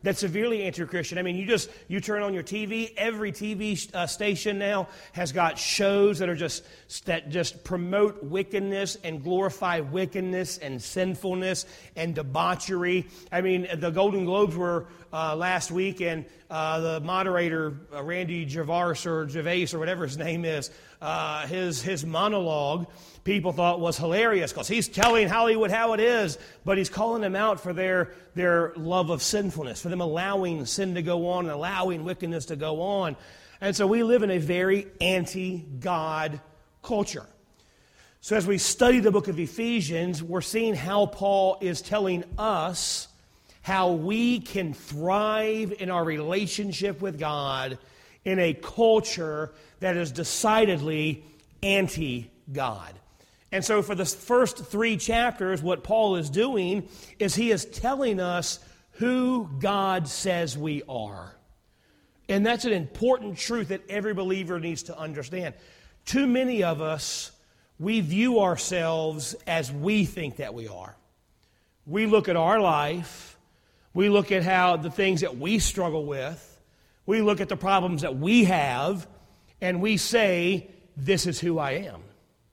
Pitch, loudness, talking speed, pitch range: 180 Hz, -26 LUFS, 155 wpm, 160-200 Hz